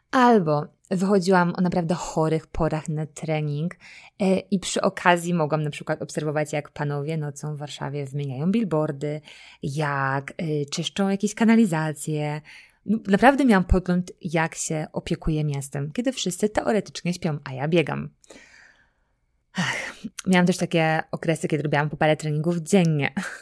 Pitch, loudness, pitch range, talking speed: 160 Hz, -24 LUFS, 150-185 Hz, 135 wpm